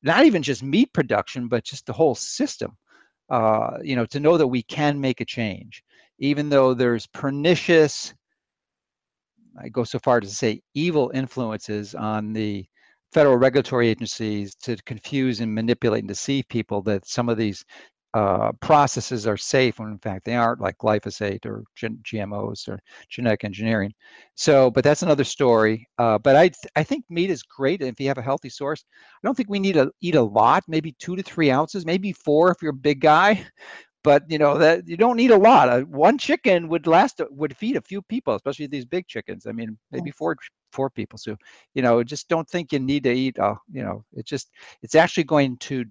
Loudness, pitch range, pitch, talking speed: -21 LUFS, 115-160 Hz, 130 Hz, 205 wpm